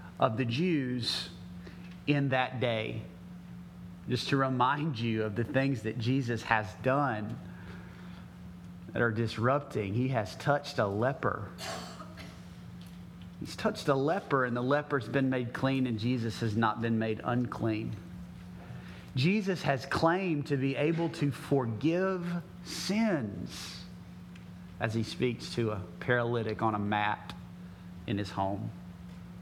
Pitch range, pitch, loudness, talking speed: 90-135 Hz, 115 Hz, -31 LUFS, 130 wpm